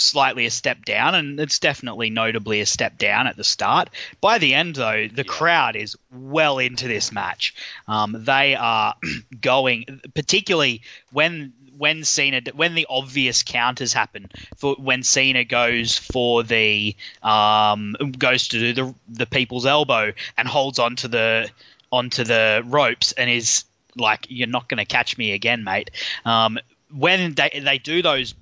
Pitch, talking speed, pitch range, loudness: 125 Hz, 160 wpm, 115-140 Hz, -19 LUFS